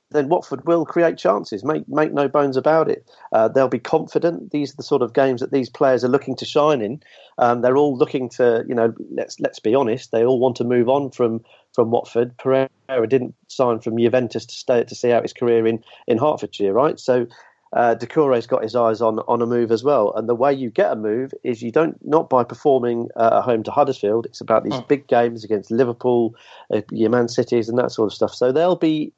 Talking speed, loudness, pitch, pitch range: 235 wpm, -19 LUFS, 125 Hz, 115-140 Hz